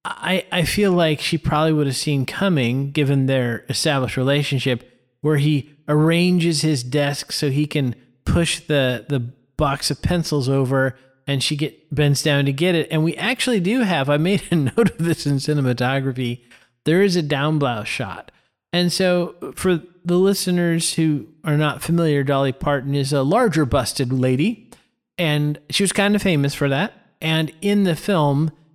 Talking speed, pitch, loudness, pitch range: 175 wpm, 150 Hz, -20 LUFS, 140-170 Hz